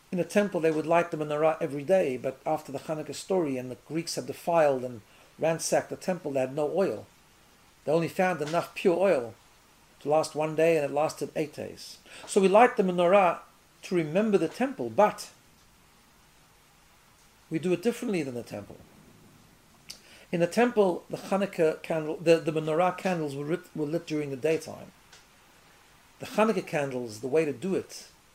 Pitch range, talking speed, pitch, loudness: 150-185 Hz, 180 wpm, 160 Hz, -28 LUFS